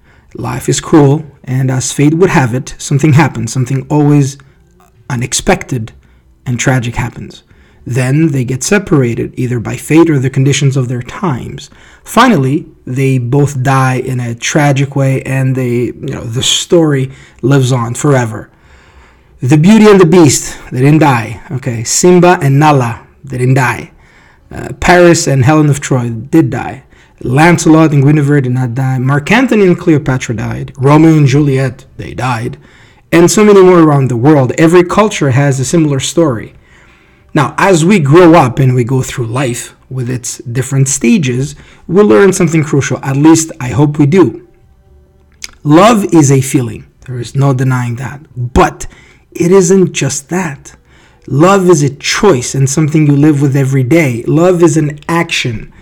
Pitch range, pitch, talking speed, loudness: 125-160 Hz, 140 Hz, 165 wpm, -9 LUFS